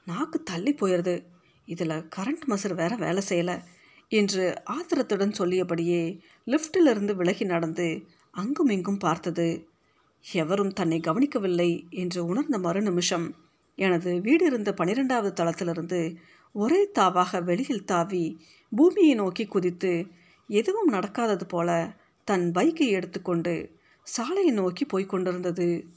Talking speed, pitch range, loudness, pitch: 105 wpm, 175-215 Hz, -26 LUFS, 185 Hz